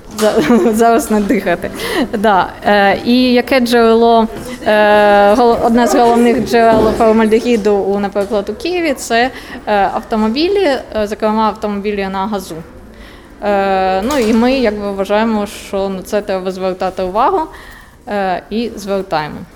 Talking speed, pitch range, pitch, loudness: 125 wpm, 200-235 Hz, 215 Hz, -13 LUFS